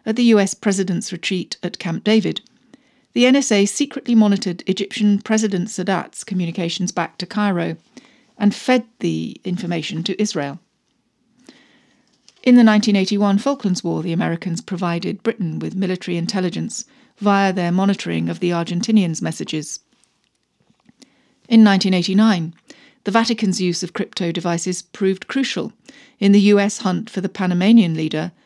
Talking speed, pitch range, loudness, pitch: 130 wpm, 180-230 Hz, -18 LUFS, 200 Hz